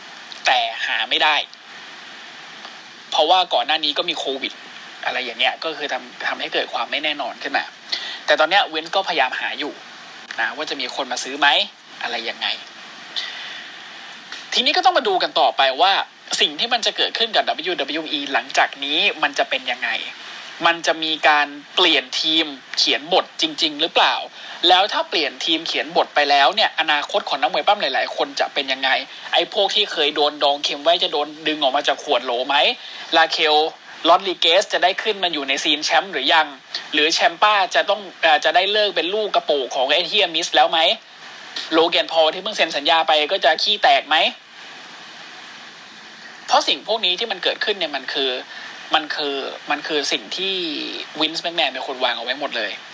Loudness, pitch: -18 LUFS, 180 Hz